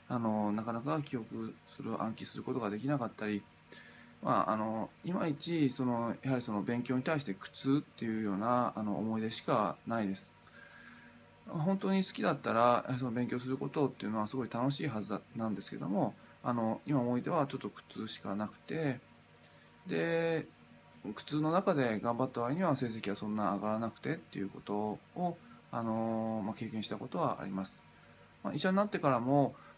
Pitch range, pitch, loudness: 100-135 Hz, 115 Hz, -35 LUFS